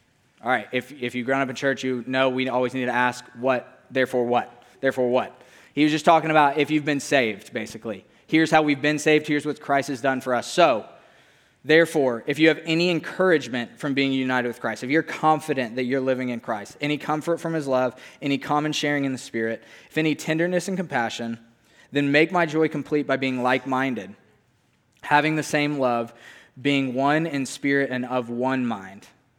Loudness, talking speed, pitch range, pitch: -23 LUFS, 205 wpm, 125-150 Hz, 135 Hz